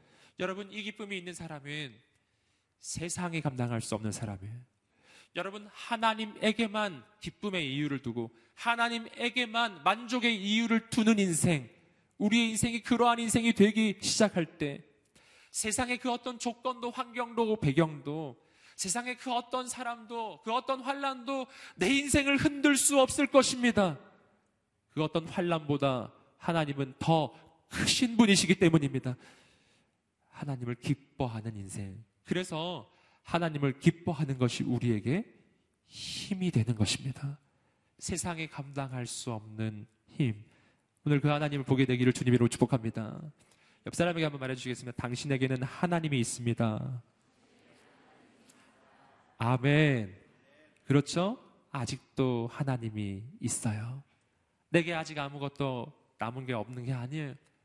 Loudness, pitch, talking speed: -31 LUFS, 155 Hz, 280 characters per minute